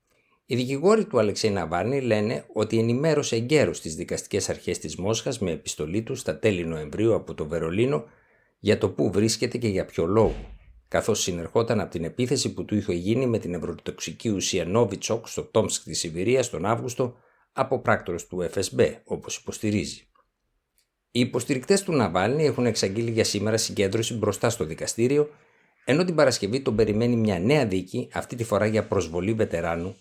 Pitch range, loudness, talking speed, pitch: 95-125 Hz, -25 LUFS, 165 wpm, 110 Hz